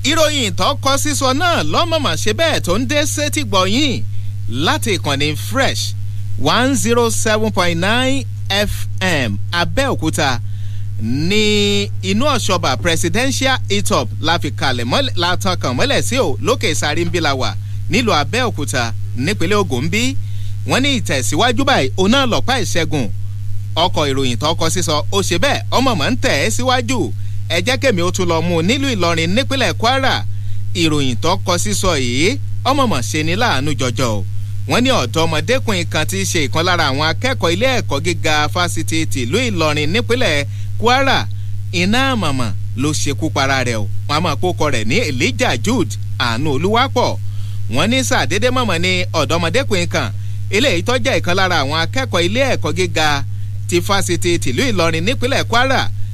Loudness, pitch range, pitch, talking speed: -16 LUFS, 100-110 Hz, 100 Hz, 135 wpm